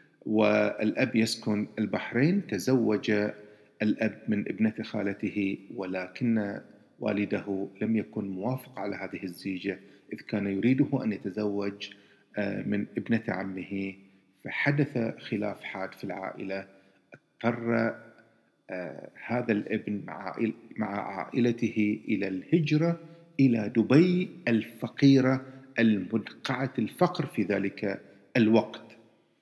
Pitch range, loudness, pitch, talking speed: 100-120 Hz, -29 LUFS, 110 Hz, 90 wpm